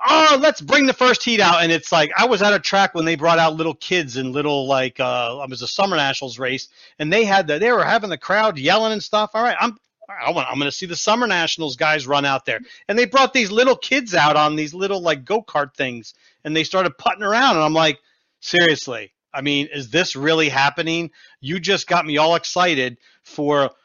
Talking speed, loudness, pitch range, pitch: 235 wpm, -18 LUFS, 145-200 Hz, 165 Hz